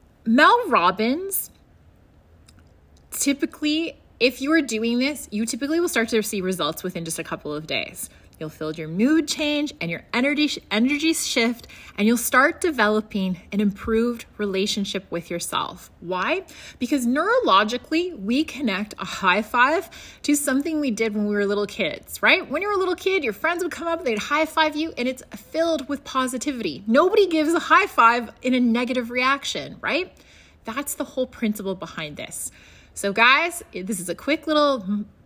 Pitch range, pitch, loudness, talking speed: 205-300 Hz, 245 Hz, -22 LUFS, 170 wpm